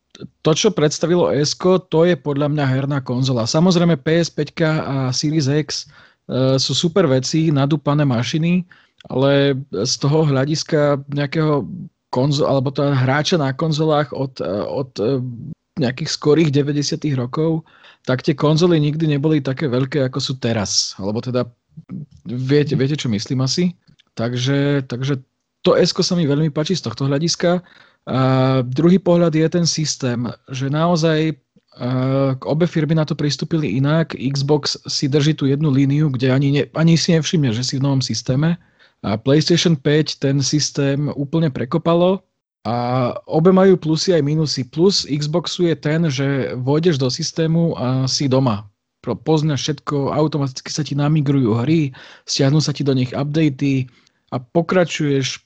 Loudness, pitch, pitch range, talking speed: -18 LUFS, 145 Hz, 135-160 Hz, 145 wpm